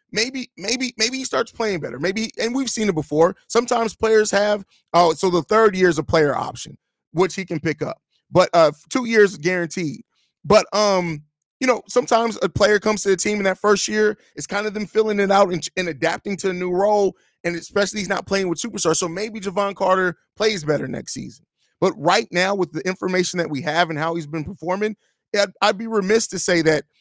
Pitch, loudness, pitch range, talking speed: 195 Hz, -20 LUFS, 175-215 Hz, 225 wpm